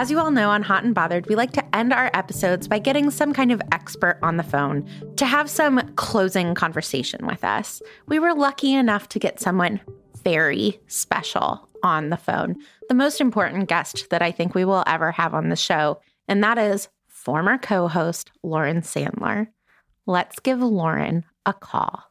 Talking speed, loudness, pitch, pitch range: 185 wpm, -22 LUFS, 200 Hz, 170-255 Hz